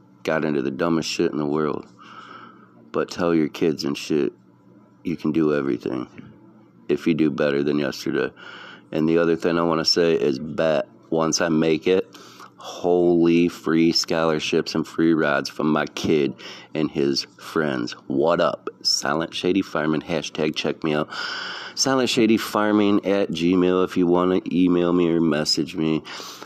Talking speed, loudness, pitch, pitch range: 165 wpm, -22 LUFS, 85 Hz, 75-90 Hz